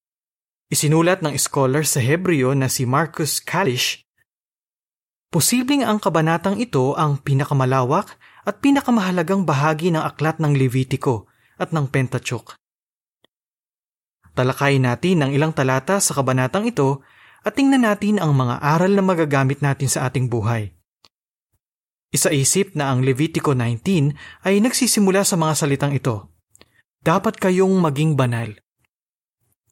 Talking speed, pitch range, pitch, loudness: 120 wpm, 130-185 Hz, 150 Hz, -19 LUFS